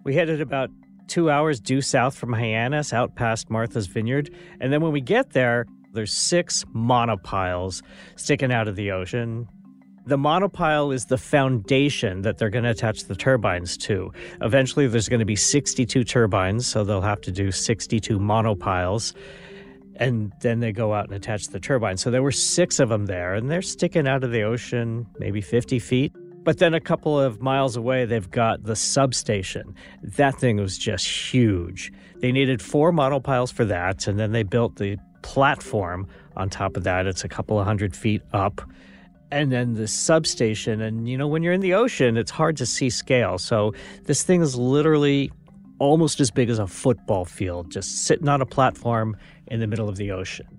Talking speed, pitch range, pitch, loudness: 190 wpm, 105-140 Hz, 120 Hz, -23 LUFS